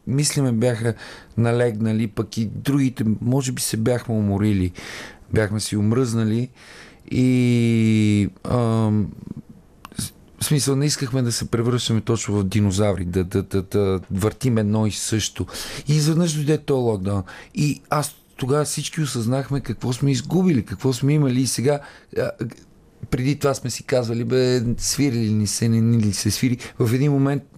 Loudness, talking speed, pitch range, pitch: -21 LUFS, 155 wpm, 105-135 Hz, 120 Hz